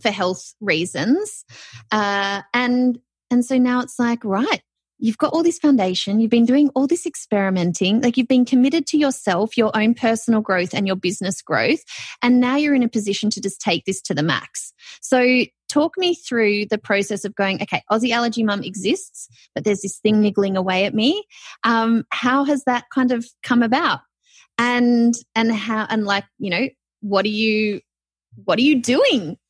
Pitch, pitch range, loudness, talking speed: 230 Hz, 200-255 Hz, -19 LUFS, 185 wpm